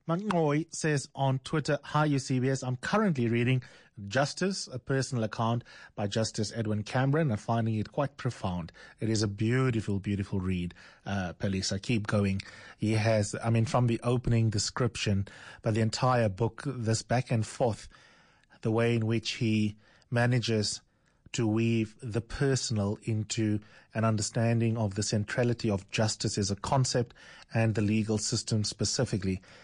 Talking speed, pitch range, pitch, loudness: 150 wpm, 105-125 Hz, 115 Hz, -30 LUFS